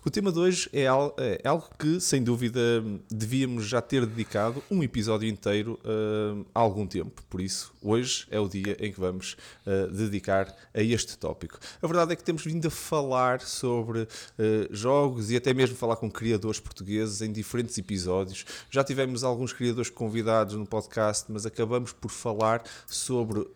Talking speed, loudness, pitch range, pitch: 175 wpm, -28 LUFS, 105-125 Hz, 115 Hz